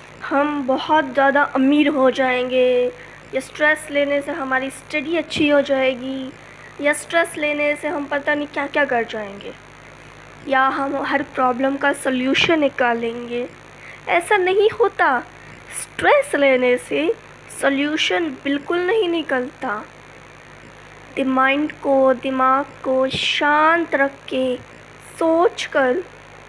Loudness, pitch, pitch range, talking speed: -19 LUFS, 280 Hz, 265-300 Hz, 120 wpm